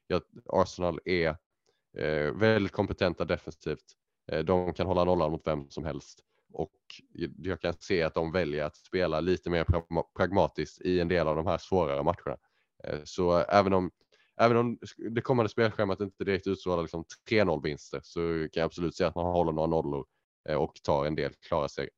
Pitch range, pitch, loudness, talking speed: 80-95 Hz, 90 Hz, -30 LUFS, 170 wpm